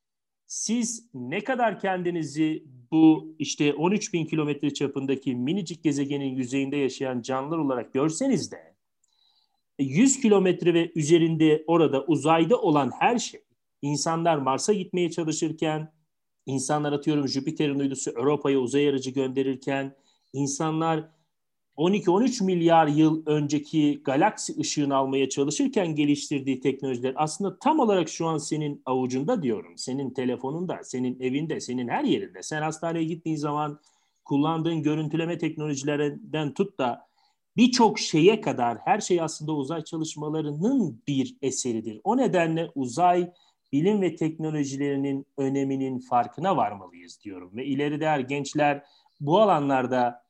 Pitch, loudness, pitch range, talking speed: 150 Hz, -25 LUFS, 135-170 Hz, 120 wpm